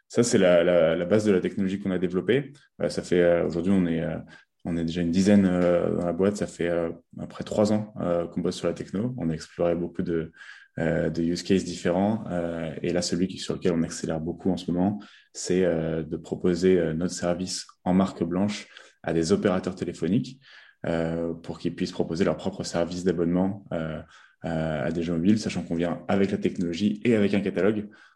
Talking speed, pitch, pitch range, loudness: 215 wpm, 85 Hz, 85-95 Hz, -26 LUFS